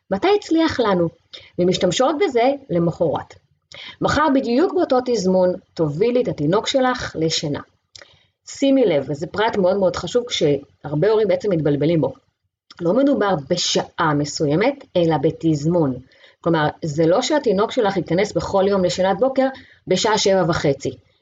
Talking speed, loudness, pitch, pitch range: 130 wpm, -19 LUFS, 180 Hz, 160-245 Hz